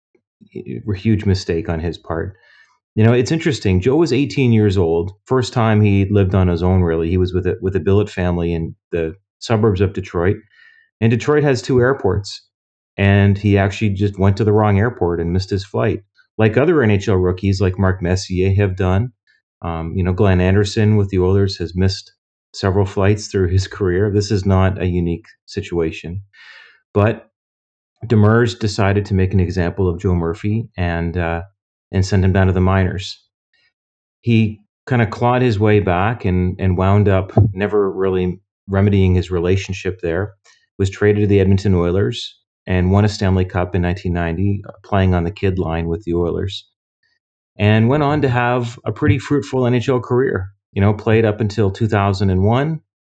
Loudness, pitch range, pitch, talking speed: -17 LUFS, 90-105 Hz, 100 Hz, 180 wpm